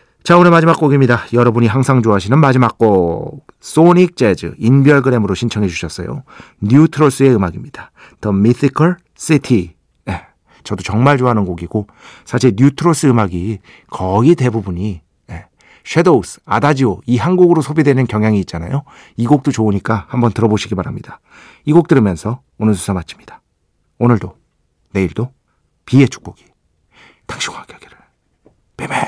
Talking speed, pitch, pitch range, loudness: 345 characters per minute, 120 Hz, 100-140 Hz, -13 LUFS